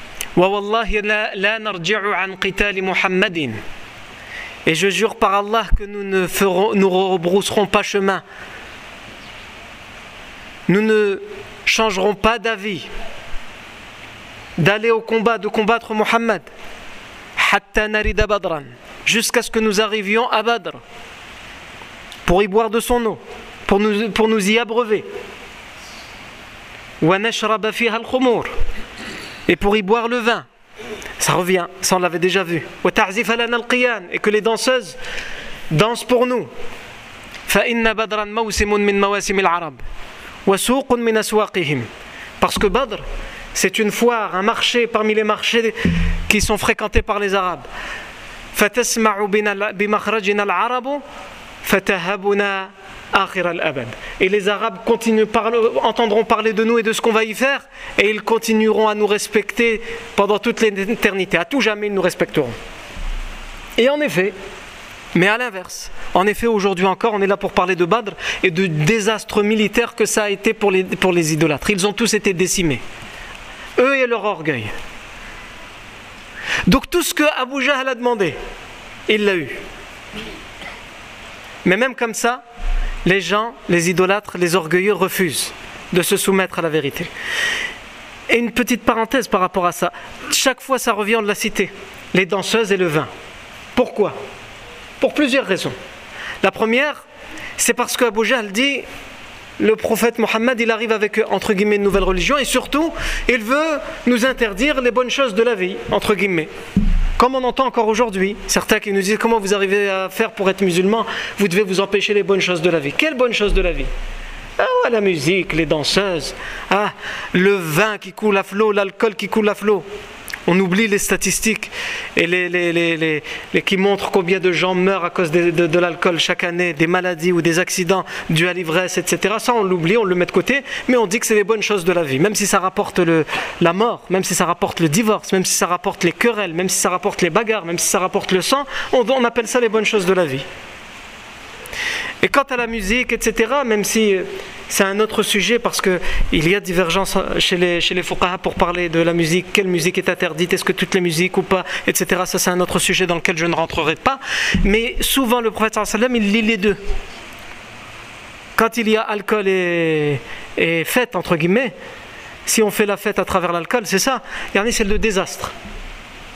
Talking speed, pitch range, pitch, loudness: 170 wpm, 185-225 Hz, 205 Hz, -17 LUFS